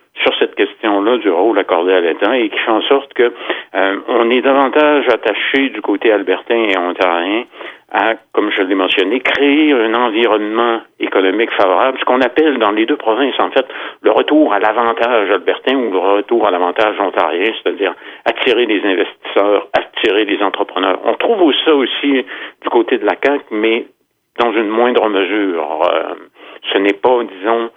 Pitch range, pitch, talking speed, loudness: 105-140 Hz, 115 Hz, 175 wpm, -14 LUFS